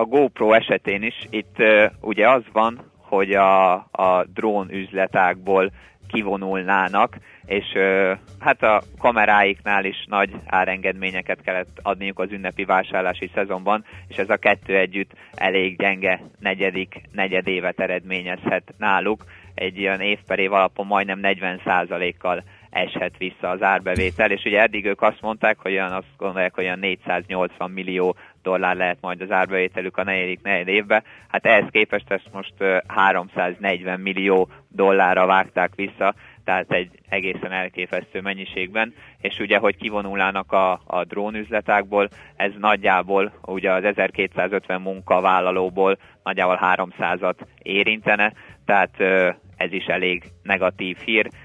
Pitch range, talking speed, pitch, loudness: 95-100 Hz, 130 wpm, 95 Hz, -21 LUFS